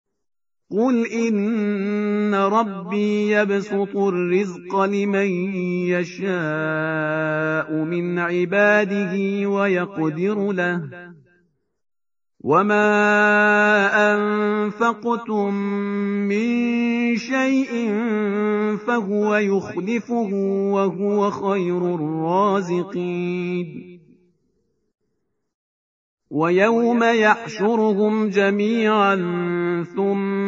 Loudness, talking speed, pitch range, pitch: -20 LUFS, 45 wpm, 180-210 Hz, 200 Hz